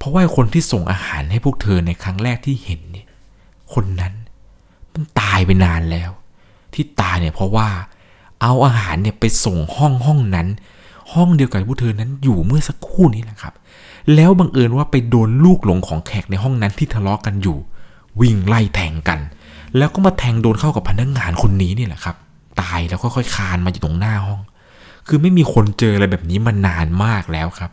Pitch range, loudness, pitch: 90-125 Hz, -16 LUFS, 105 Hz